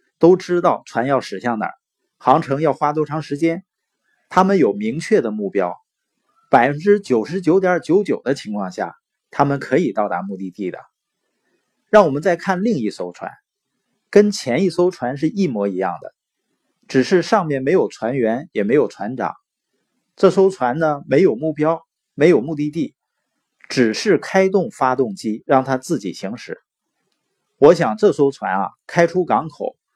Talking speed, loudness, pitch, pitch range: 230 characters per minute, -18 LUFS, 170 Hz, 140-200 Hz